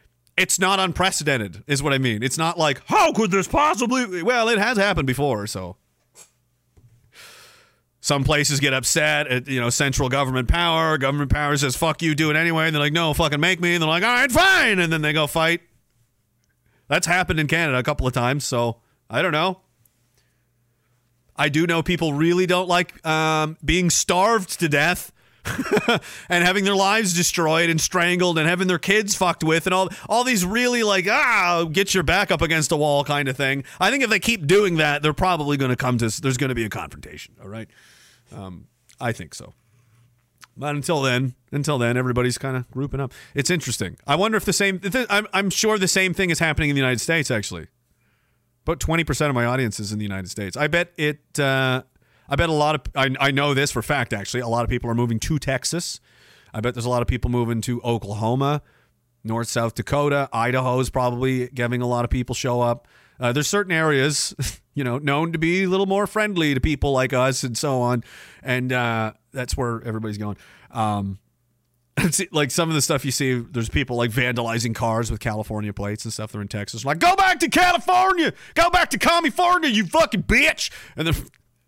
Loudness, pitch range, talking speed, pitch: -21 LUFS, 120-175 Hz, 210 wpm, 140 Hz